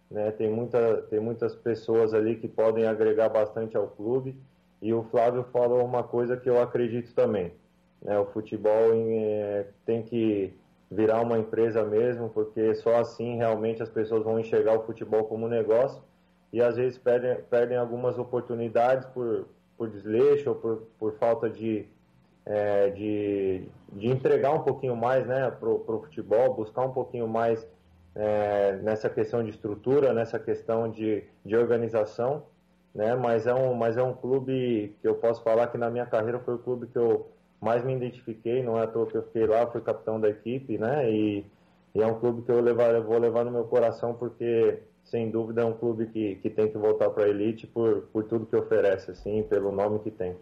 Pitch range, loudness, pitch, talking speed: 110-120 Hz, -27 LUFS, 115 Hz, 195 wpm